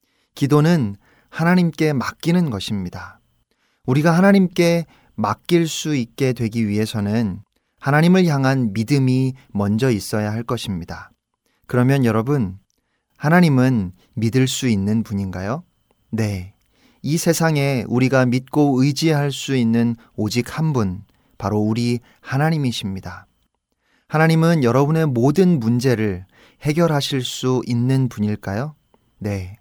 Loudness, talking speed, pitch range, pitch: -19 LUFS, 255 characters per minute, 110-150 Hz, 125 Hz